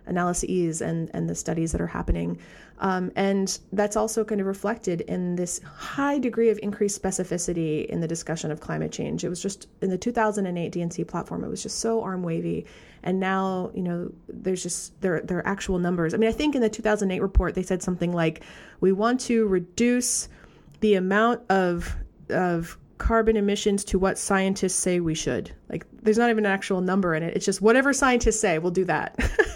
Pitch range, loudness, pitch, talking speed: 175-215 Hz, -25 LUFS, 190 Hz, 200 wpm